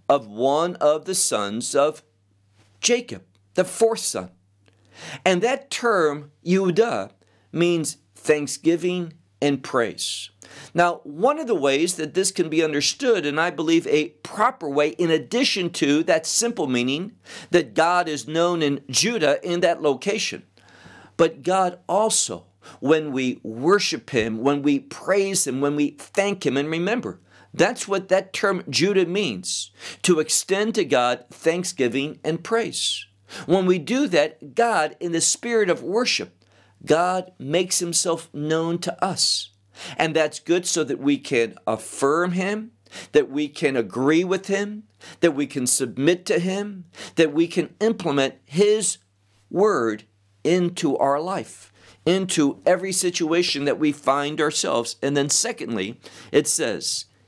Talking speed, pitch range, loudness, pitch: 145 wpm, 135-185 Hz, -22 LUFS, 160 Hz